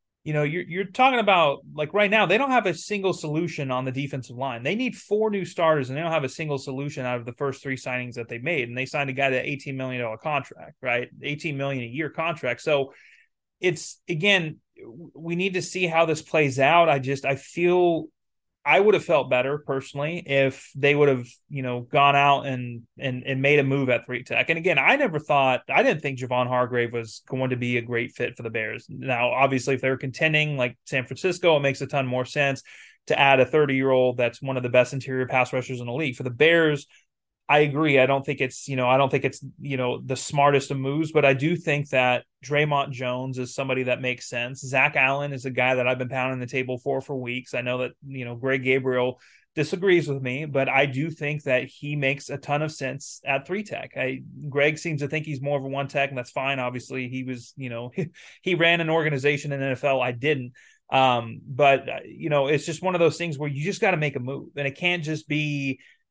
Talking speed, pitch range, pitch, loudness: 240 wpm, 130-155 Hz, 140 Hz, -24 LUFS